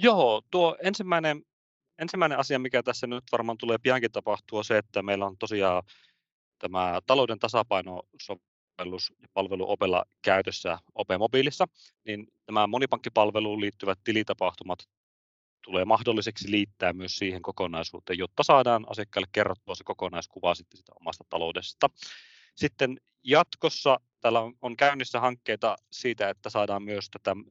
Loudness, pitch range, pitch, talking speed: -28 LUFS, 95-130 Hz, 105 Hz, 130 wpm